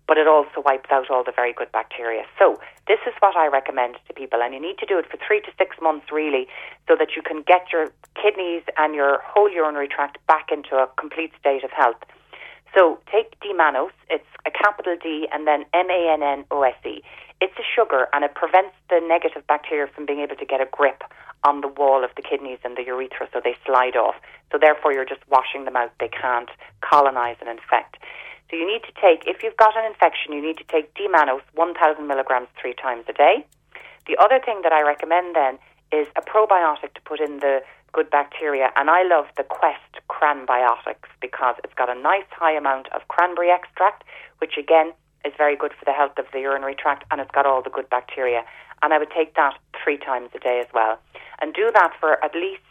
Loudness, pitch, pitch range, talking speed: -21 LUFS, 150 Hz, 135-175 Hz, 215 wpm